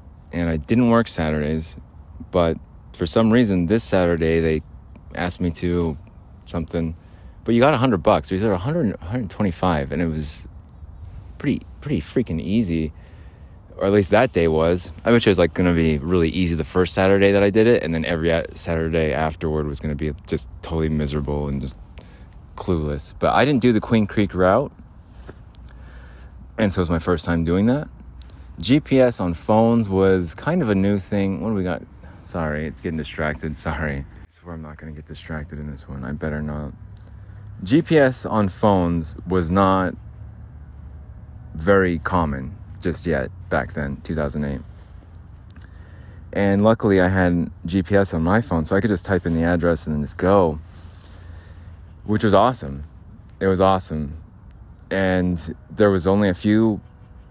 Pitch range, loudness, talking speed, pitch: 80-95 Hz, -20 LUFS, 170 wpm, 85 Hz